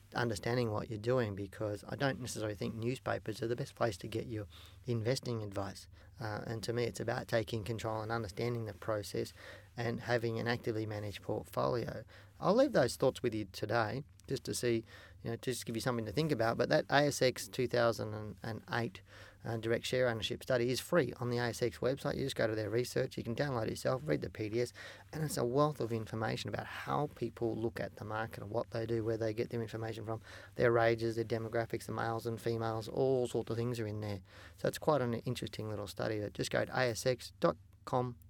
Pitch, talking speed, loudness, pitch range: 115 Hz, 210 wpm, -36 LUFS, 110-120 Hz